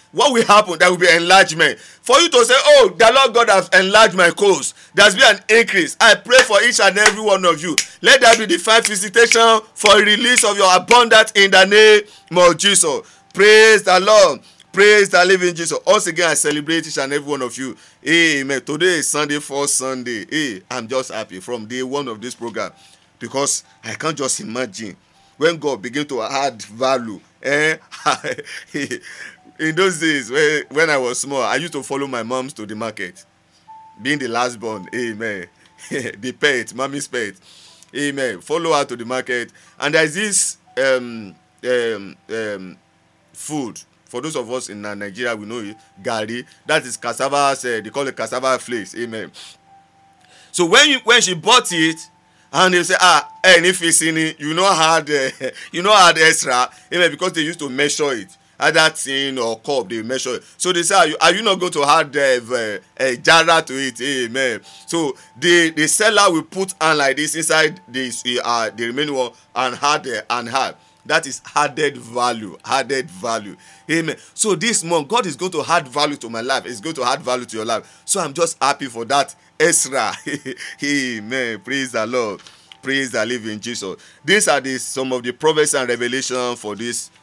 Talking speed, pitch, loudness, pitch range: 195 wpm, 145 Hz, -15 LUFS, 125-180 Hz